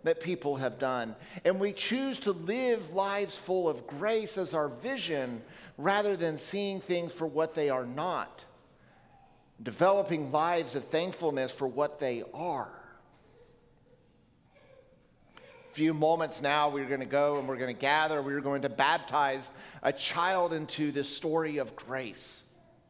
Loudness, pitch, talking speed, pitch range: -31 LUFS, 160 Hz, 145 wpm, 140-190 Hz